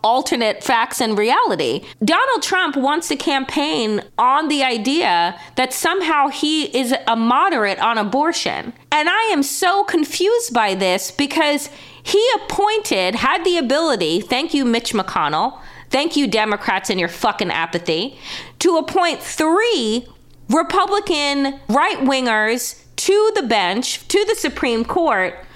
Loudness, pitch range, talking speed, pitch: -18 LUFS, 230-340 Hz, 135 wpm, 285 Hz